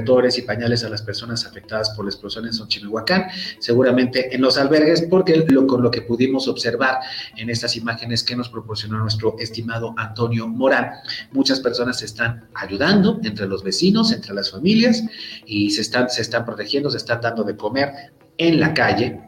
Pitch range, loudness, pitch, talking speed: 110-140 Hz, -19 LUFS, 120 Hz, 175 wpm